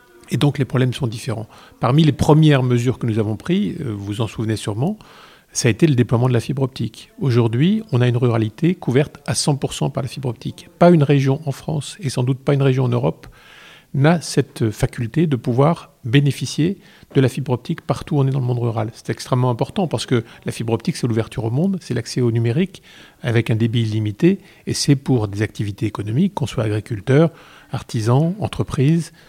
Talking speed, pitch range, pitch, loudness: 210 wpm, 115-155 Hz, 130 Hz, -19 LUFS